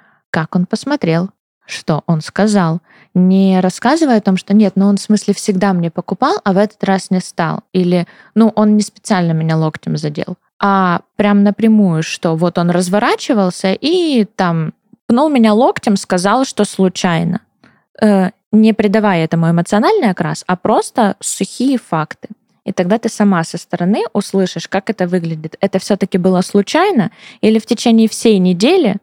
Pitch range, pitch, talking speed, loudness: 180-220 Hz, 200 Hz, 160 wpm, -14 LUFS